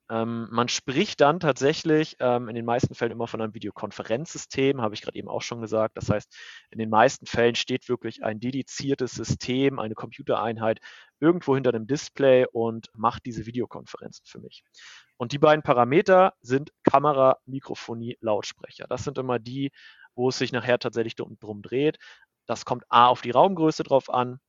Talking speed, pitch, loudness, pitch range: 175 wpm, 125 Hz, -25 LUFS, 115-135 Hz